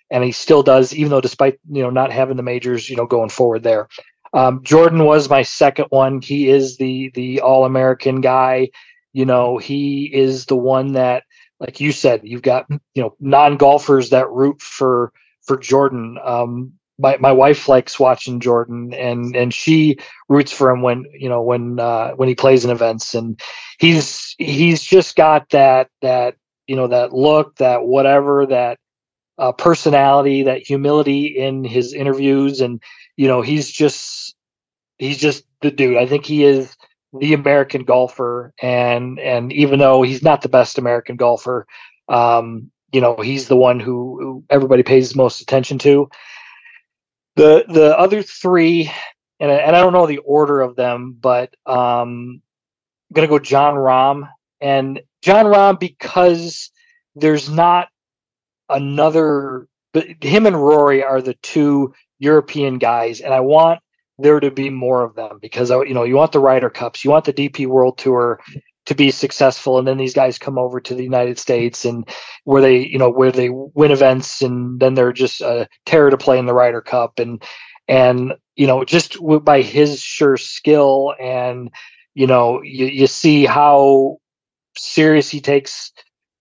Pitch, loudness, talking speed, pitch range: 135 Hz, -14 LUFS, 170 wpm, 125-145 Hz